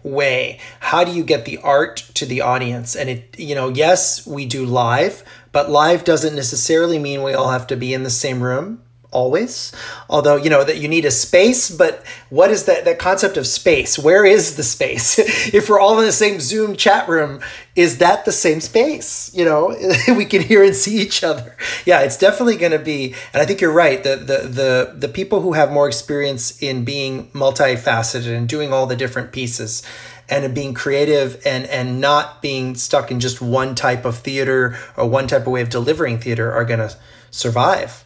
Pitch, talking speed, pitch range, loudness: 140 Hz, 205 wpm, 125-175 Hz, -16 LUFS